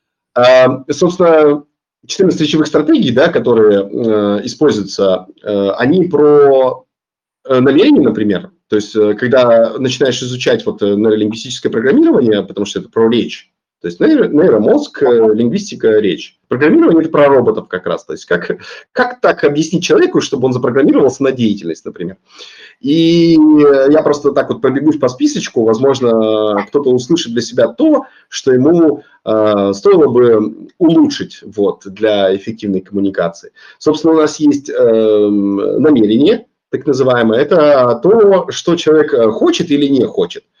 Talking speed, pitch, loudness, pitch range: 135 wpm, 135 Hz, -11 LUFS, 110-165 Hz